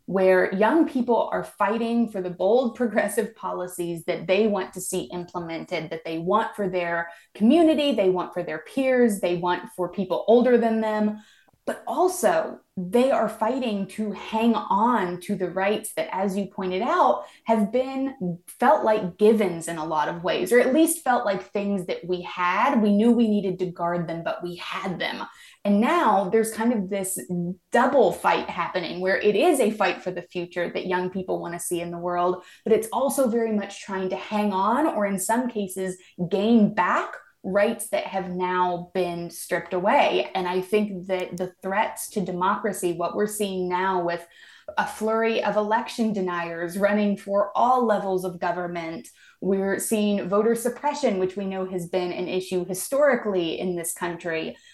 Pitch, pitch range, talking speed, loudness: 195 Hz, 180-220 Hz, 185 wpm, -24 LUFS